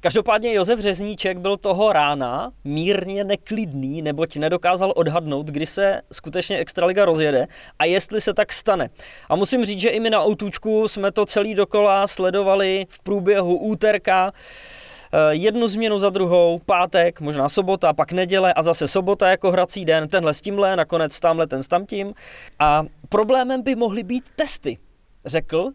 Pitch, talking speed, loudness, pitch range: 195 Hz, 155 wpm, -20 LUFS, 165-210 Hz